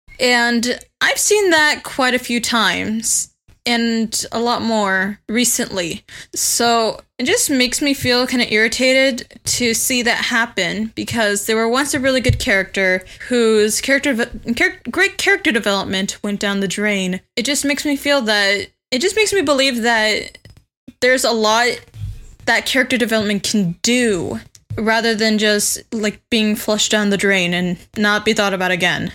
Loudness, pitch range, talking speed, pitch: -16 LUFS, 205-255 Hz, 160 wpm, 230 Hz